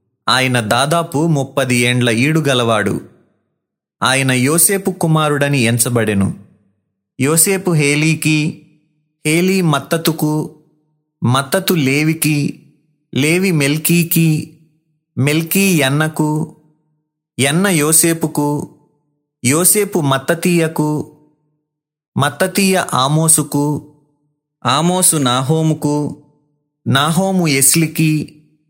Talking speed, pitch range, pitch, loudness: 60 wpm, 140-160 Hz, 150 Hz, -14 LUFS